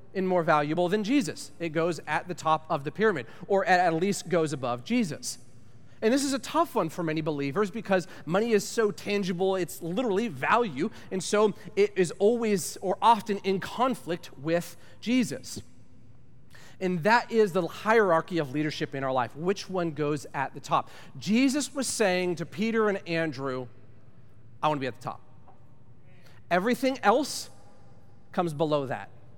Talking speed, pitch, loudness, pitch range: 165 wpm, 170 Hz, -27 LUFS, 130-200 Hz